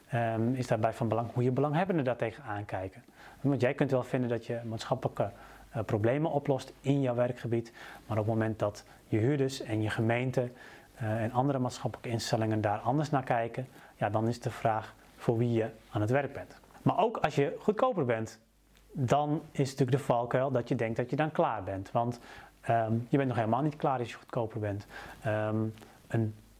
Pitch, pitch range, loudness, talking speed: 120 Hz, 110-135 Hz, -32 LUFS, 200 wpm